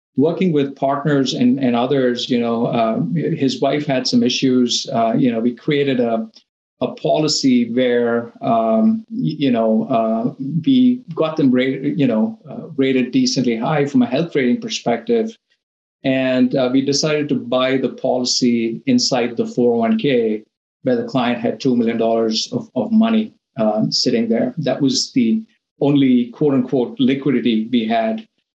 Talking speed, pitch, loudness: 160 wpm, 135 Hz, -17 LUFS